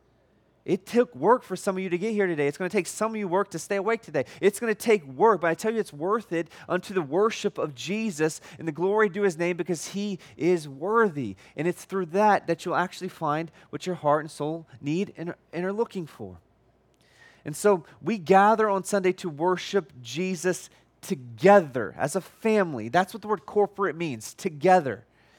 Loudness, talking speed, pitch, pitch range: -26 LUFS, 210 wpm, 185 Hz, 160-200 Hz